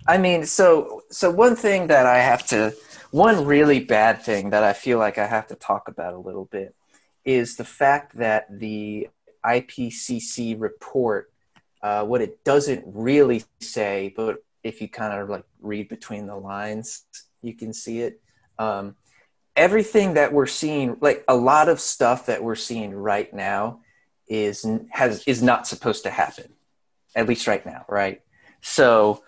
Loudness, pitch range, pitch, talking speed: -21 LUFS, 105-140 Hz, 115 Hz, 165 wpm